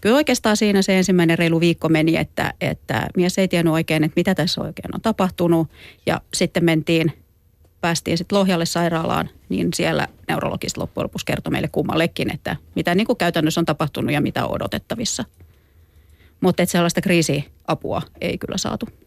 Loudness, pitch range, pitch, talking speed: -20 LUFS, 155-185 Hz, 170 Hz, 165 wpm